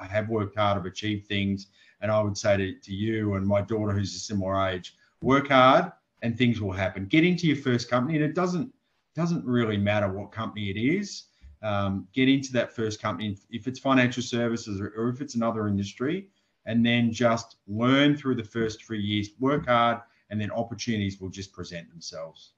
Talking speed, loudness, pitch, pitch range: 200 wpm, -26 LUFS, 110 Hz, 100-125 Hz